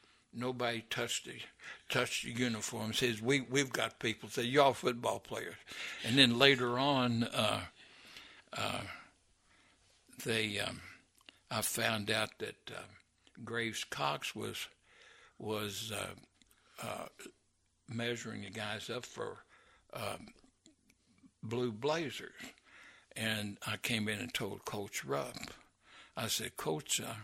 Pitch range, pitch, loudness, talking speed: 110-125 Hz, 115 Hz, -35 LUFS, 120 wpm